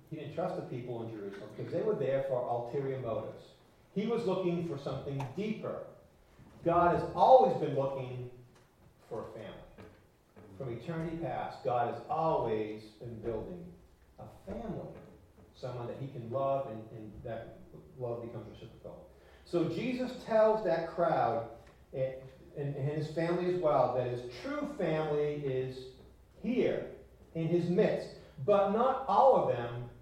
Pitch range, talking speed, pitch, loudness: 120-175 Hz, 150 wpm, 140 Hz, -33 LUFS